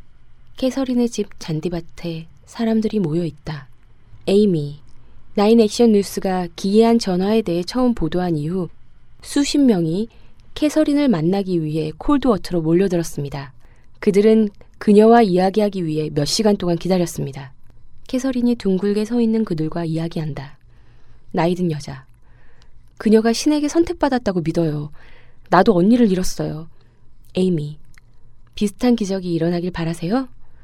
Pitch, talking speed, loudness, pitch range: 180 Hz, 305 characters per minute, -19 LUFS, 155-220 Hz